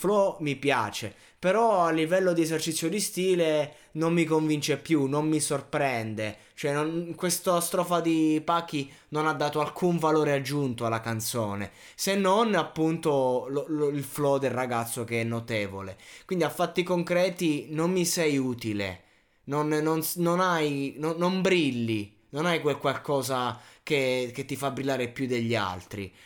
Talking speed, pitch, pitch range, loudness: 160 wpm, 150 Hz, 125-165 Hz, -27 LUFS